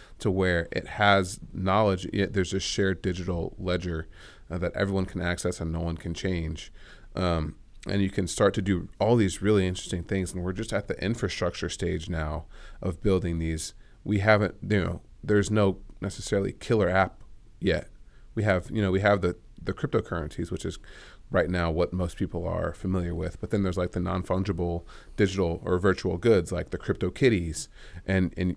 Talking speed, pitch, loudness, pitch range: 185 wpm, 95 Hz, -28 LUFS, 85-100 Hz